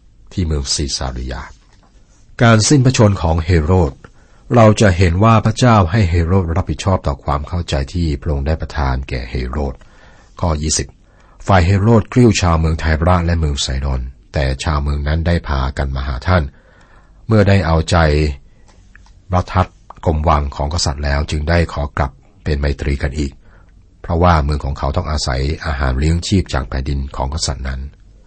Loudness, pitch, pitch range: -16 LUFS, 80 Hz, 70-95 Hz